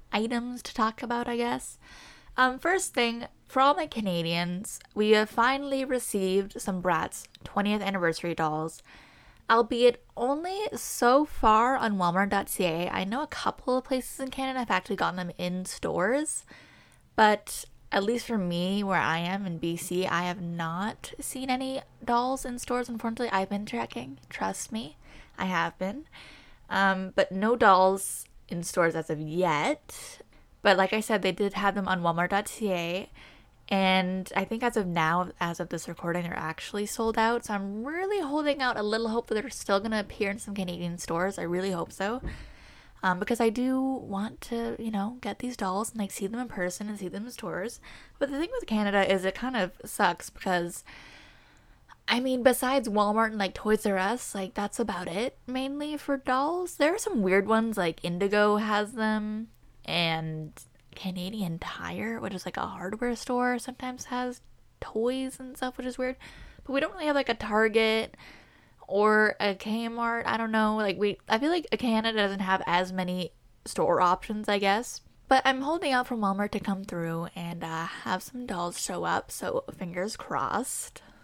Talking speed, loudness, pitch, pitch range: 180 wpm, -28 LUFS, 210 Hz, 185-245 Hz